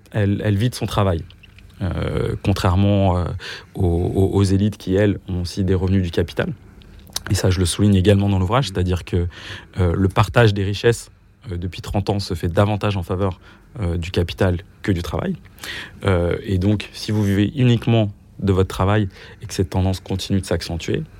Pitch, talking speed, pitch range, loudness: 100 Hz, 190 wpm, 95-105 Hz, -20 LUFS